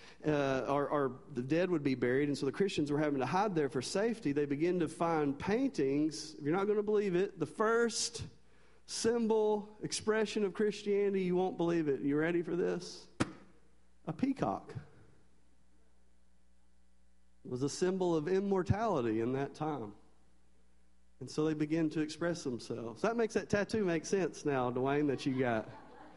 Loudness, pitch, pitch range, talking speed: -34 LUFS, 150 Hz, 125-190 Hz, 175 wpm